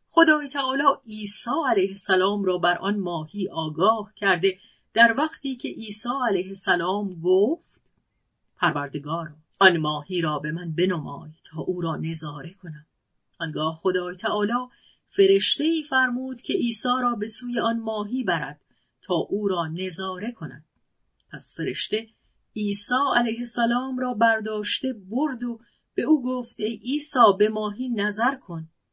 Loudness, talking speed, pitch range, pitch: -24 LUFS, 140 wpm, 175-245 Hz, 210 Hz